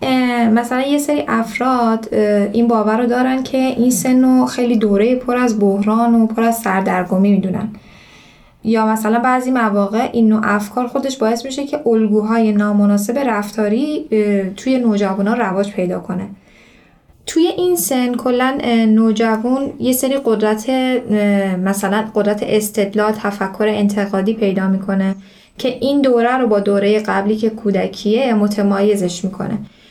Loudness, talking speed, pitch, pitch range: -16 LUFS, 135 wpm, 220 Hz, 205-250 Hz